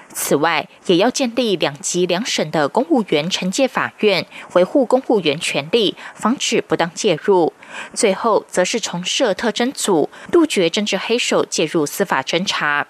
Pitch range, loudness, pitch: 175-240 Hz, -18 LUFS, 195 Hz